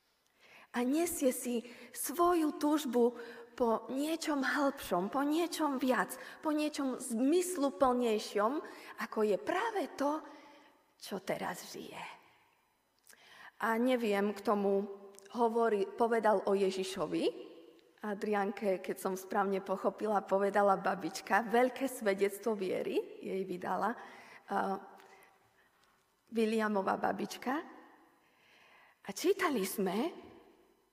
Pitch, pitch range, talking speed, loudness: 240 Hz, 200-300 Hz, 90 wpm, -34 LUFS